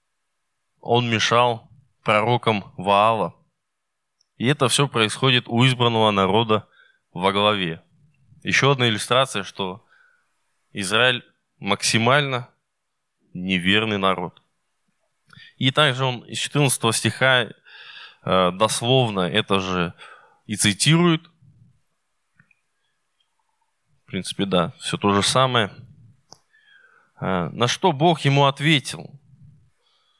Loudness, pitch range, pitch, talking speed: -20 LUFS, 110-140 Hz, 125 Hz, 85 wpm